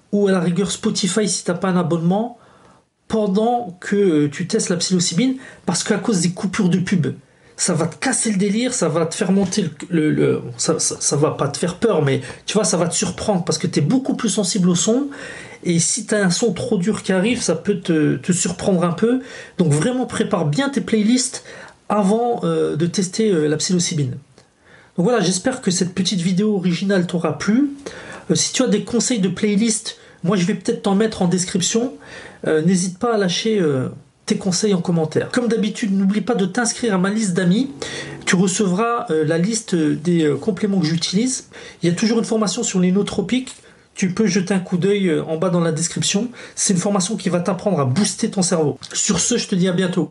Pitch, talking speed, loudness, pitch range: 195 Hz, 225 wpm, -19 LUFS, 175-220 Hz